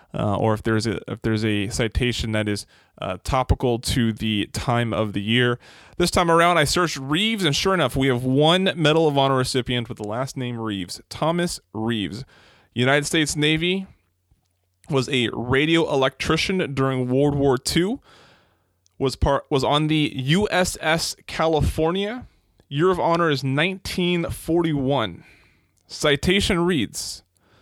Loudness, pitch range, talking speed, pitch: -22 LUFS, 110-160 Hz, 145 wpm, 135 Hz